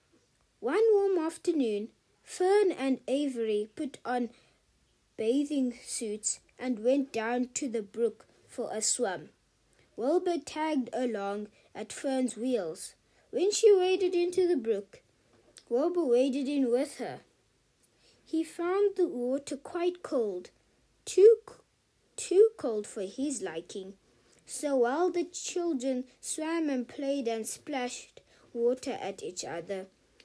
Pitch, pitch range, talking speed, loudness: 275 Hz, 240-355 Hz, 120 wpm, -30 LUFS